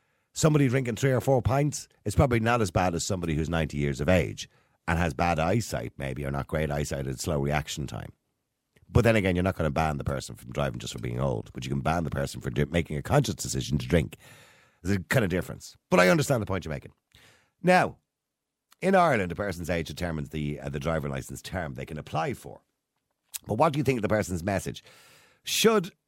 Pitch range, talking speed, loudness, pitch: 70-110 Hz, 230 wpm, -27 LUFS, 85 Hz